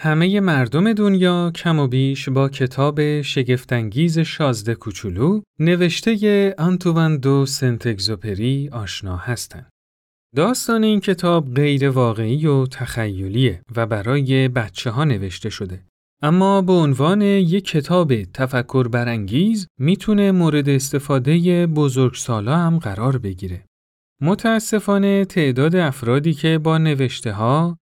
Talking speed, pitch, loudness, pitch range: 115 wpm, 140 Hz, -18 LUFS, 120-170 Hz